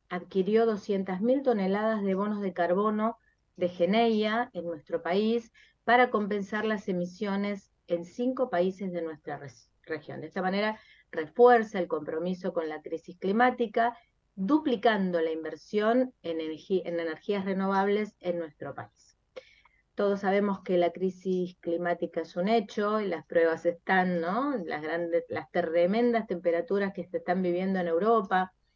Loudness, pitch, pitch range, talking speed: -29 LUFS, 190 Hz, 170-215 Hz, 145 wpm